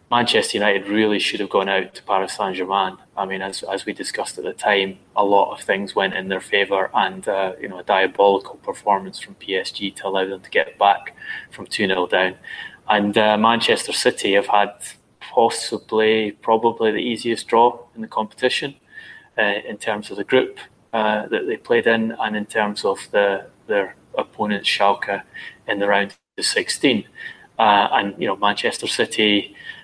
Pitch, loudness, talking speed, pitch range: 105 Hz, -20 LUFS, 180 wpm, 100-115 Hz